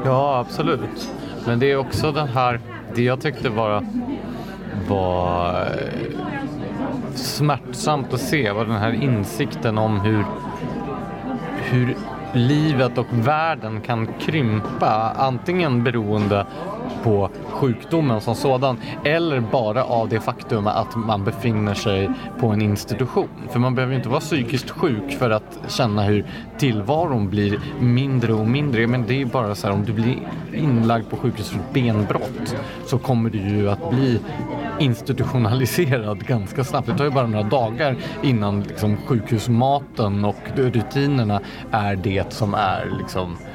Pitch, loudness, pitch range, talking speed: 120 Hz, -21 LUFS, 110-135 Hz, 140 wpm